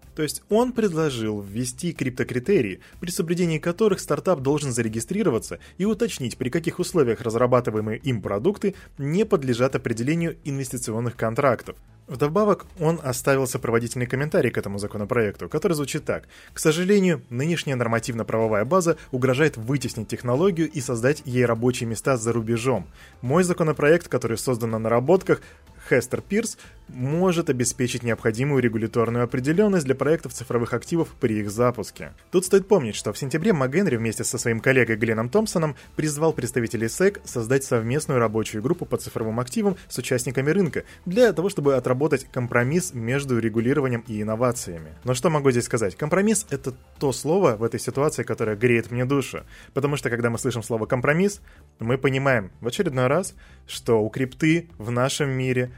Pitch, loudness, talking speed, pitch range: 130 Hz, -23 LUFS, 150 wpm, 115-160 Hz